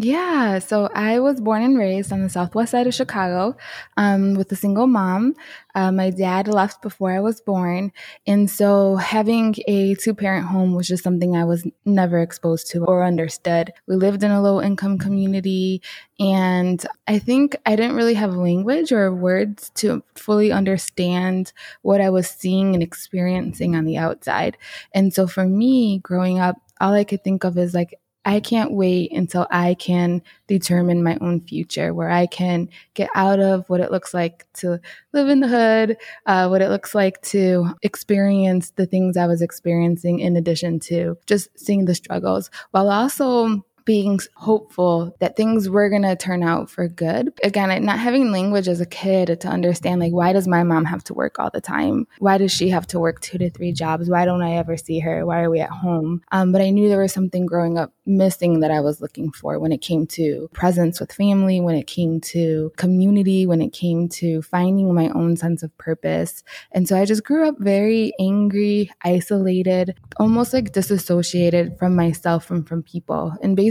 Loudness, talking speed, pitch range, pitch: -19 LUFS, 195 wpm, 175-200 Hz, 185 Hz